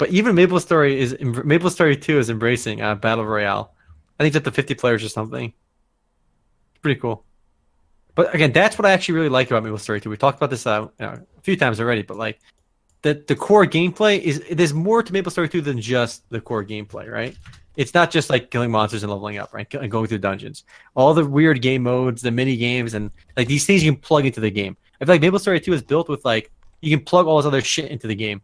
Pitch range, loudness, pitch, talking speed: 110-155 Hz, -19 LUFS, 130 Hz, 250 wpm